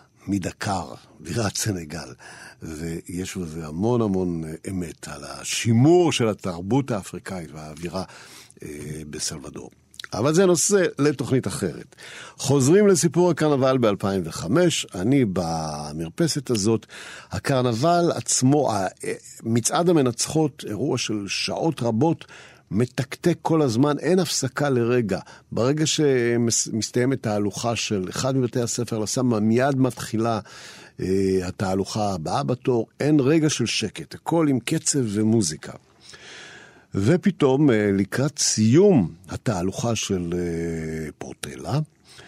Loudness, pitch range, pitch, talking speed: -22 LUFS, 95-140 Hz, 120 Hz, 100 wpm